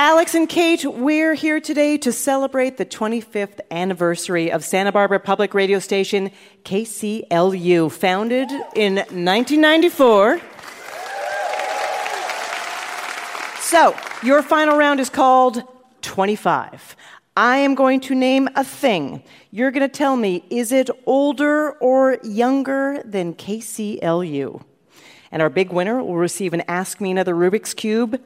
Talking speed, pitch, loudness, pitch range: 125 wpm, 235 Hz, -18 LUFS, 190-275 Hz